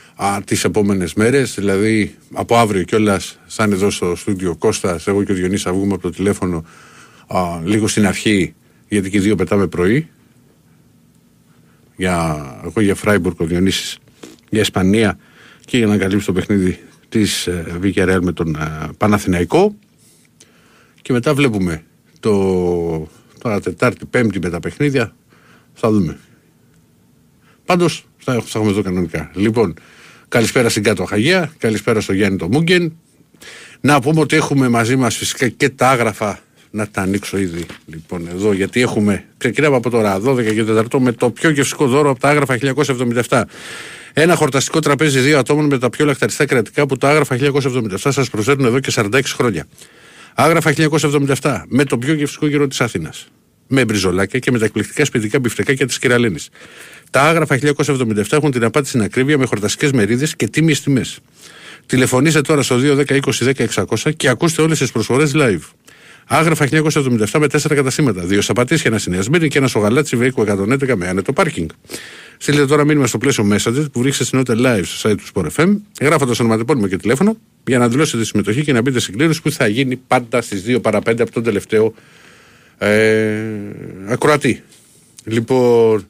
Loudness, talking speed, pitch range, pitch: -16 LUFS, 165 wpm, 100-140 Hz, 120 Hz